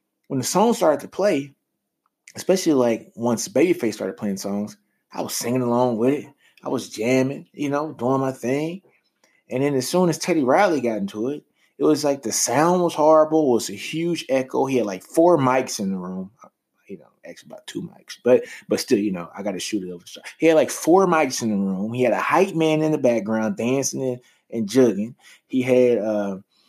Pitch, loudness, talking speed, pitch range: 130 Hz, -21 LUFS, 220 wpm, 110-155 Hz